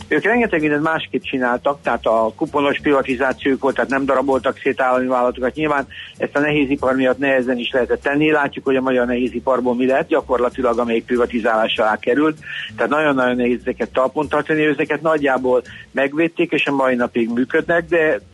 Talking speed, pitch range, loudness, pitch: 175 wpm, 125-150 Hz, -18 LUFS, 135 Hz